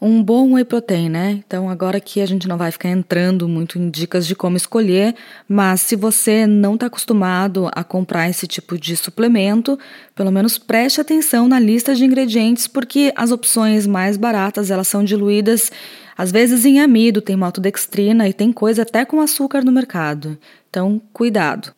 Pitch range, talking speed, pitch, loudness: 185-235 Hz, 175 wpm, 210 Hz, -15 LUFS